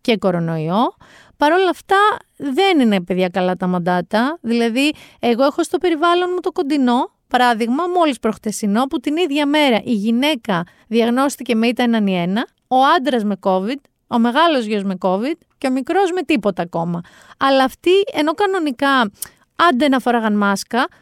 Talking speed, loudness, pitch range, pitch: 160 wpm, -17 LUFS, 215-310 Hz, 255 Hz